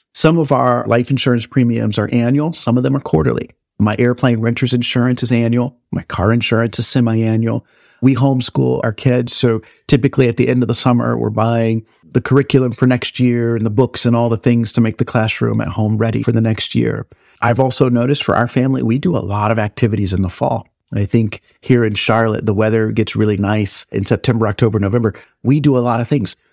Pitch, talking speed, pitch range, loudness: 120 Hz, 220 wpm, 110-125 Hz, -15 LUFS